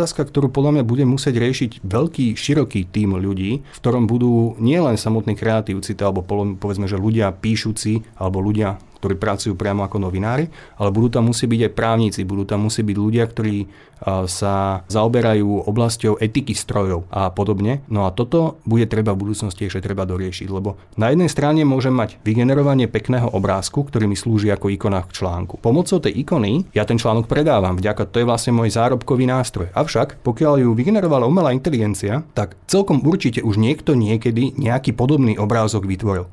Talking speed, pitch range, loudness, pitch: 170 wpm, 100-130 Hz, -19 LUFS, 110 Hz